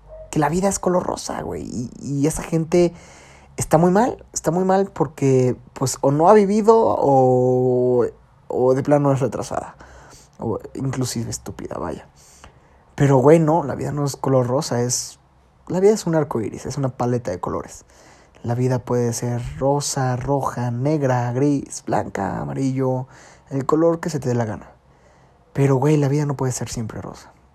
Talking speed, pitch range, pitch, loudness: 175 wpm, 125-150 Hz, 135 Hz, -20 LUFS